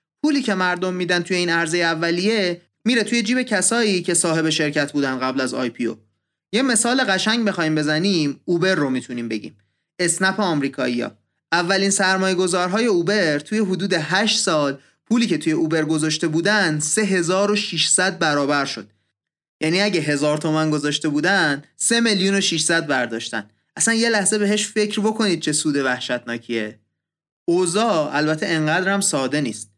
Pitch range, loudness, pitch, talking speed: 145-195 Hz, -19 LUFS, 170 Hz, 145 wpm